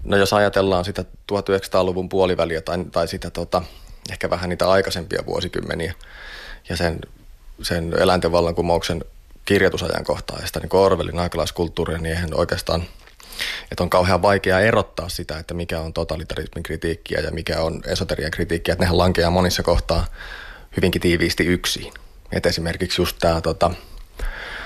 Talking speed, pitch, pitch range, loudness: 135 wpm, 85 Hz, 85-90 Hz, -21 LUFS